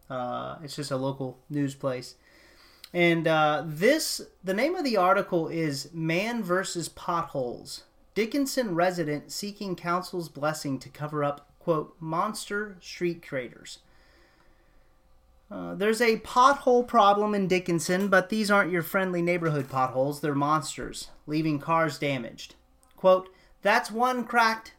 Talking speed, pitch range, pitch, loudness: 130 wpm, 145-205 Hz, 170 Hz, -27 LUFS